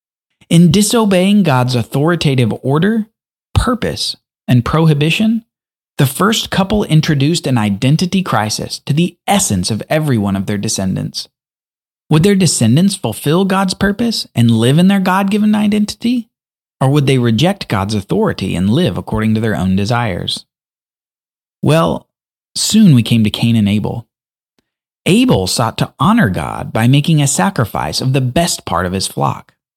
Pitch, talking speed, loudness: 150 Hz, 150 wpm, -13 LUFS